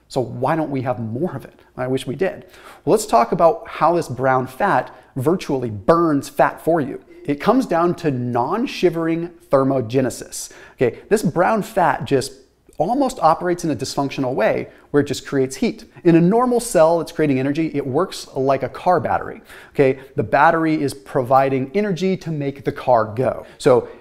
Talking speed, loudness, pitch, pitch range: 180 wpm, -19 LUFS, 145 Hz, 130-170 Hz